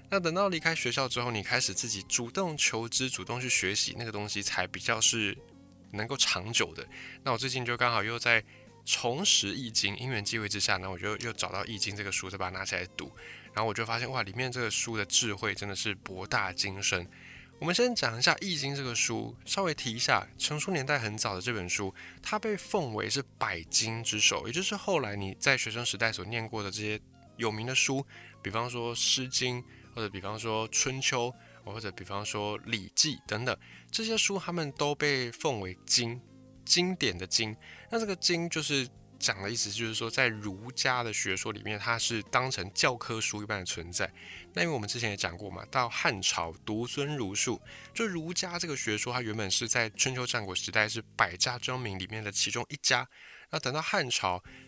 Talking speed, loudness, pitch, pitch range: 300 characters per minute, -30 LUFS, 115 Hz, 105-130 Hz